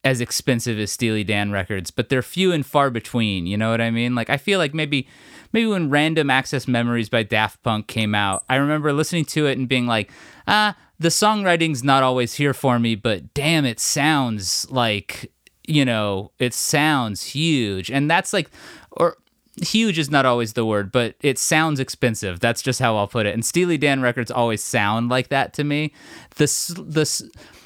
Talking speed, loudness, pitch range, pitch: 195 wpm, -20 LUFS, 115-155 Hz, 130 Hz